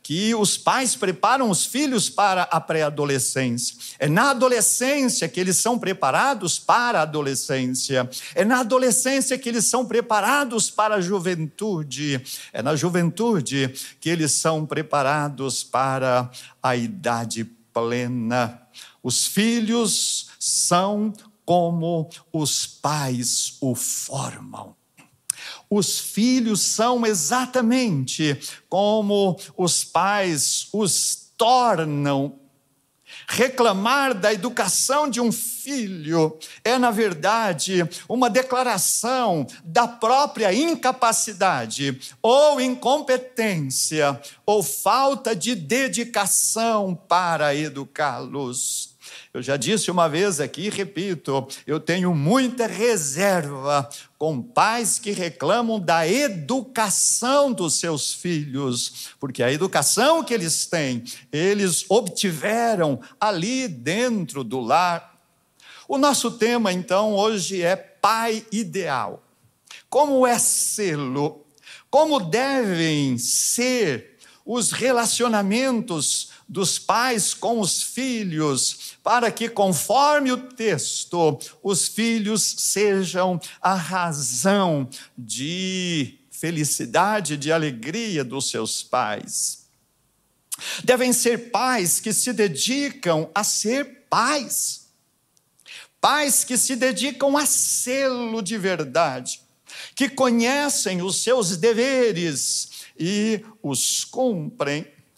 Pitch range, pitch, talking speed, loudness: 145-235 Hz, 190 Hz, 100 wpm, -21 LUFS